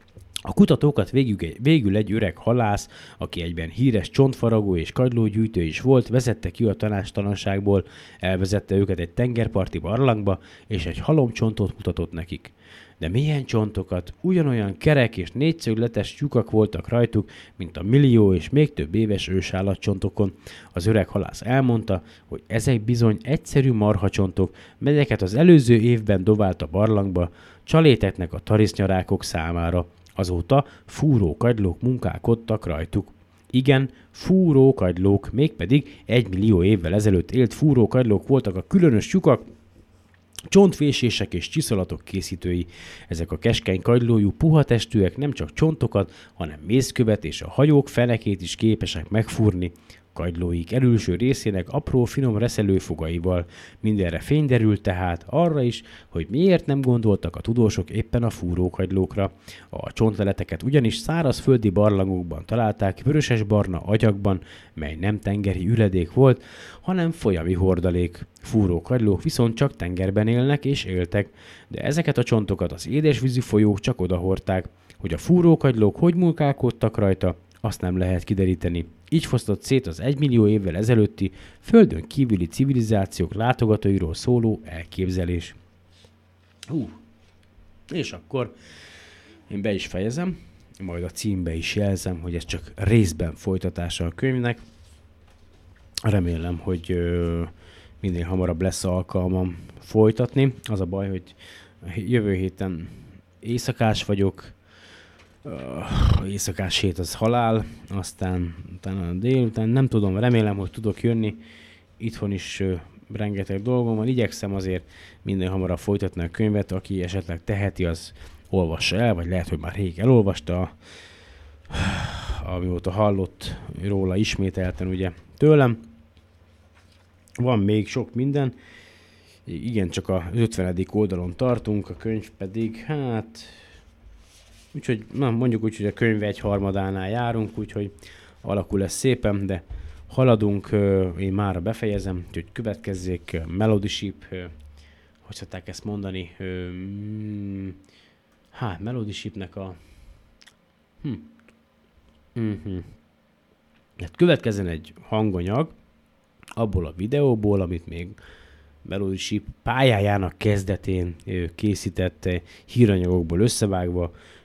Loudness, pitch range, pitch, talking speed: -23 LUFS, 90-115 Hz, 100 Hz, 120 wpm